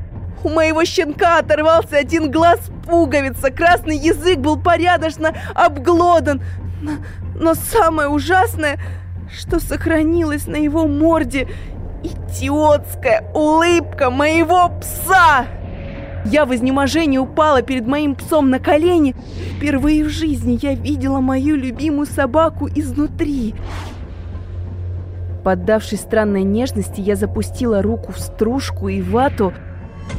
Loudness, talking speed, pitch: -16 LUFS, 105 wpm, 285 Hz